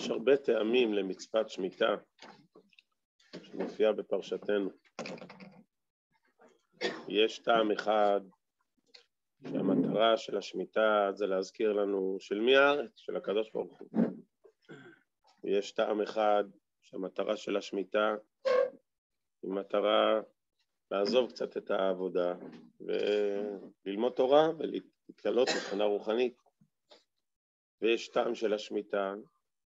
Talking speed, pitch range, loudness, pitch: 90 wpm, 100-125 Hz, -31 LUFS, 105 Hz